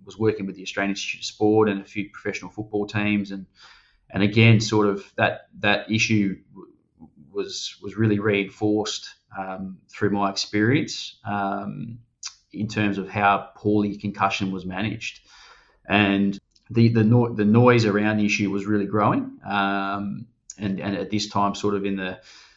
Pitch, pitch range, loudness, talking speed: 105 Hz, 100-110 Hz, -23 LUFS, 165 wpm